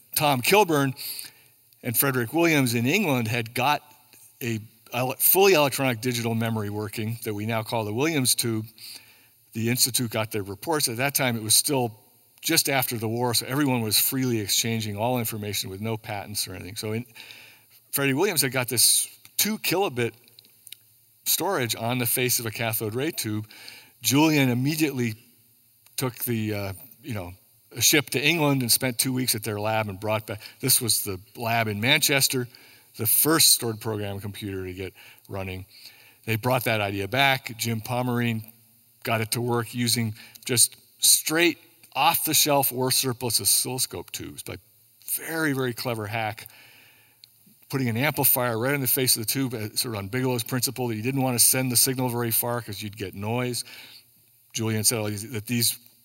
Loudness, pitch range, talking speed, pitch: -23 LUFS, 110-130 Hz, 175 wpm, 120 Hz